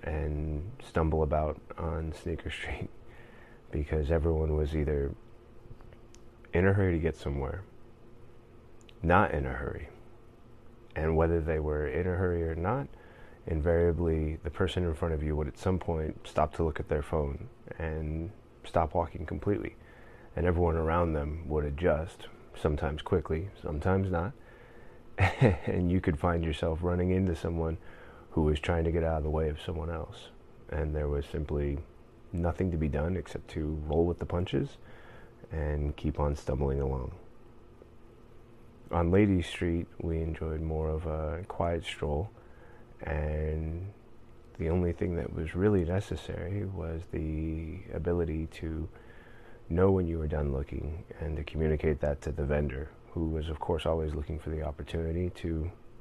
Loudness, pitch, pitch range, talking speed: -32 LUFS, 85 Hz, 80-95 Hz, 155 wpm